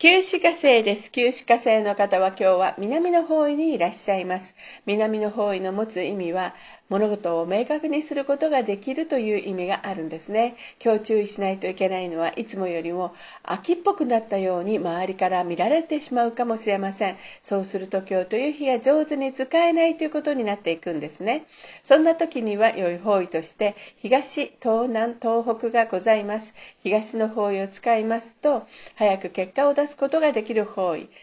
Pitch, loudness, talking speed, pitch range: 215 Hz, -23 LUFS, 380 characters per minute, 195-270 Hz